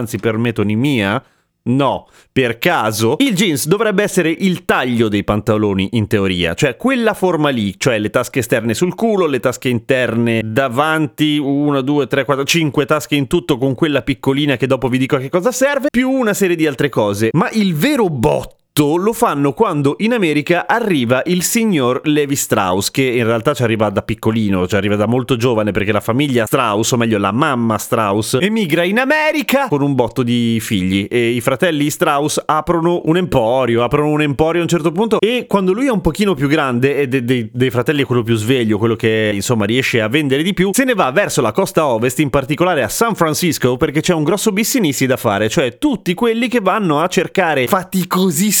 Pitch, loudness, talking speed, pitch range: 145 Hz, -15 LUFS, 200 wpm, 120-180 Hz